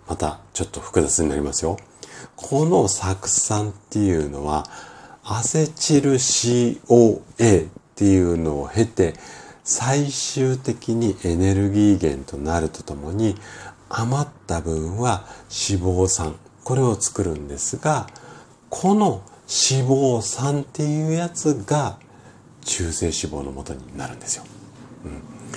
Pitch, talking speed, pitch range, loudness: 105 Hz, 240 characters per minute, 85-130 Hz, -21 LUFS